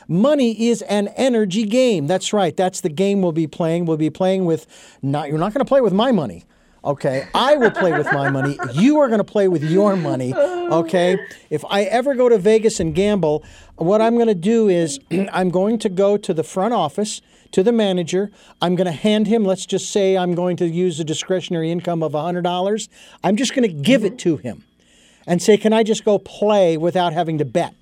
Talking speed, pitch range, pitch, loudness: 220 wpm, 170-215 Hz, 190 Hz, -18 LUFS